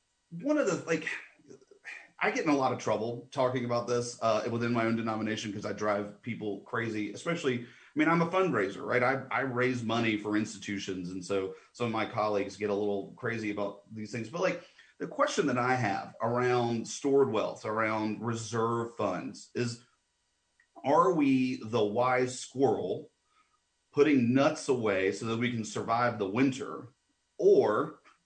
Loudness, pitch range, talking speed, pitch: -30 LUFS, 105-125 Hz, 170 wpm, 115 Hz